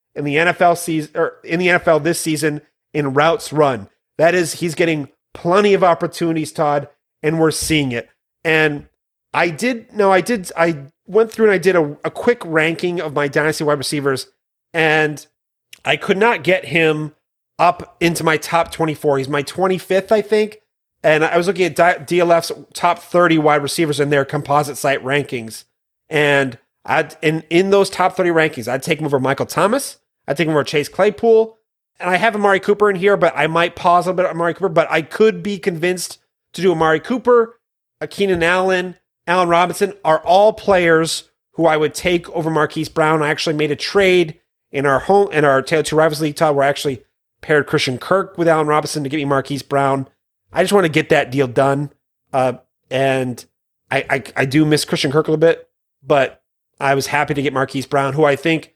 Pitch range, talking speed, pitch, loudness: 145-180 Hz, 200 wpm, 160 Hz, -17 LUFS